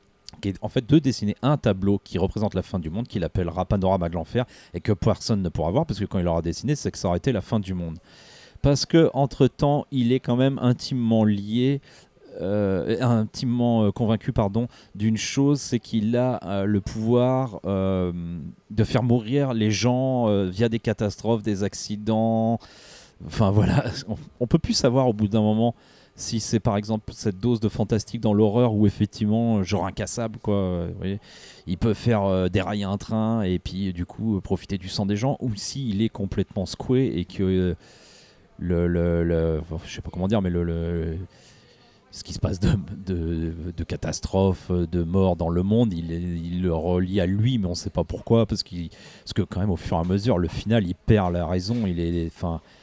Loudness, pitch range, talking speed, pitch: -24 LUFS, 90-115 Hz, 205 wpm, 105 Hz